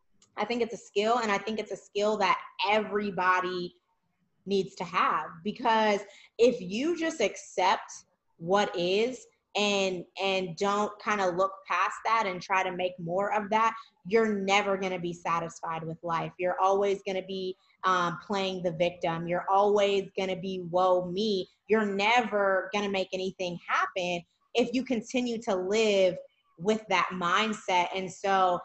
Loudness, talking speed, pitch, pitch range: -28 LUFS, 155 wpm, 195 Hz, 185-215 Hz